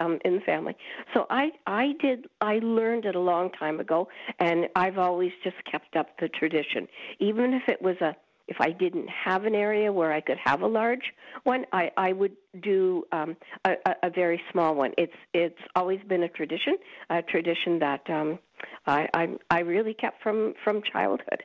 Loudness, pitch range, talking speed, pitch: -27 LUFS, 170-220 Hz, 195 wpm, 185 Hz